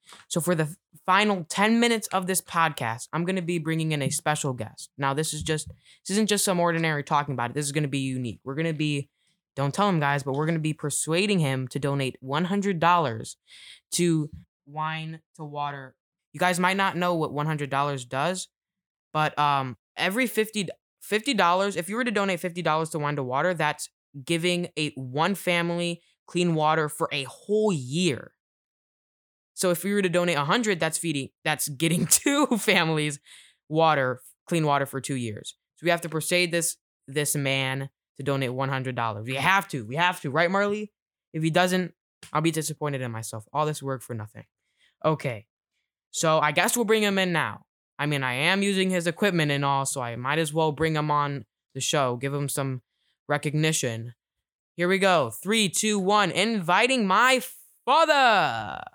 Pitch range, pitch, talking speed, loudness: 140-180 Hz, 160 Hz, 190 wpm, -25 LUFS